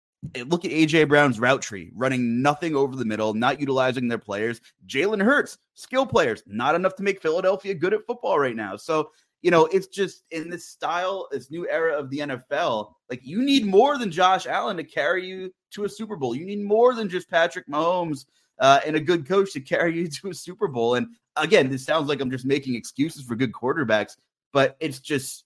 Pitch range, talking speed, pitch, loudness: 130-190 Hz, 215 wpm, 160 Hz, -23 LUFS